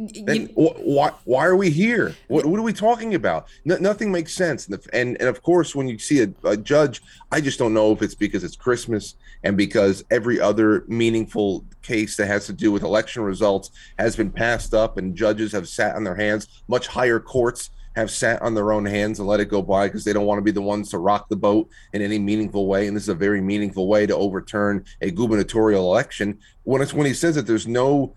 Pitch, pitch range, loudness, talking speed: 110 Hz, 105-125 Hz, -21 LUFS, 230 wpm